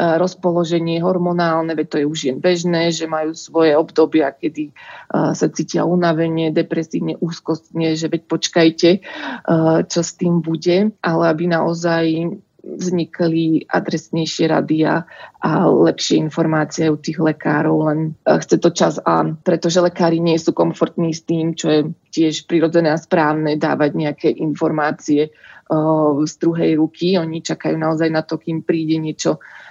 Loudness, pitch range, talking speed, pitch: -17 LUFS, 155-170 Hz, 140 wpm, 165 Hz